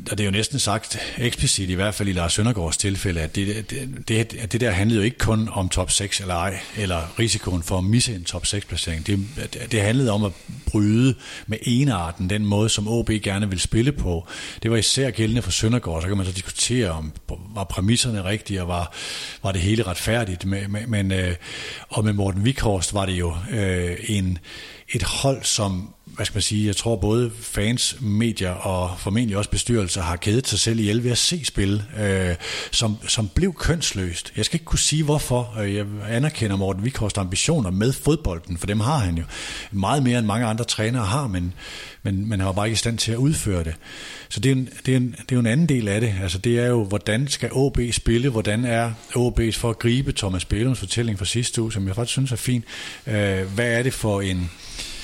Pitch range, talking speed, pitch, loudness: 95-120 Hz, 220 wpm, 105 Hz, -22 LUFS